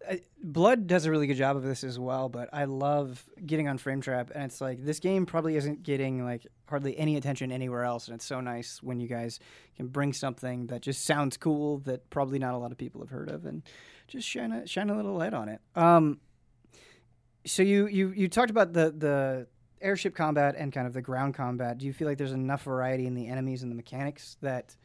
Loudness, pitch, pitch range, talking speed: -30 LUFS, 135 Hz, 125-155 Hz, 230 wpm